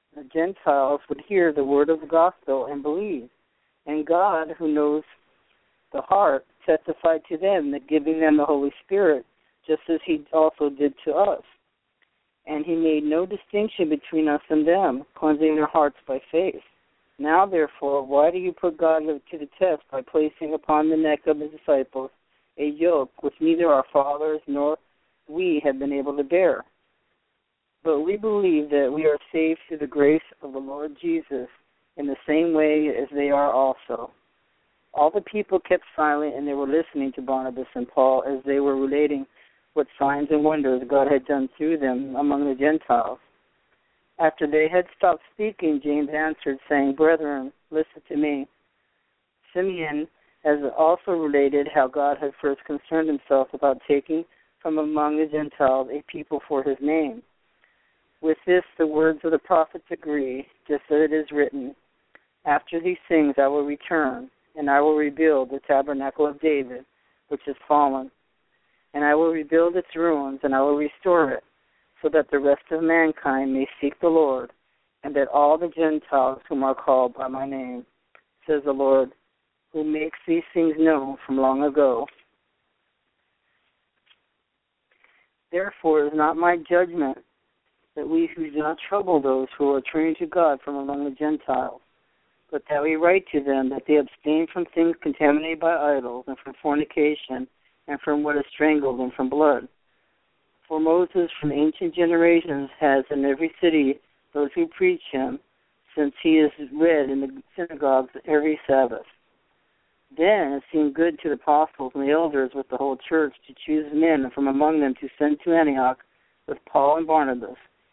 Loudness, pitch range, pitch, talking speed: -23 LUFS, 140-160 Hz, 150 Hz, 170 wpm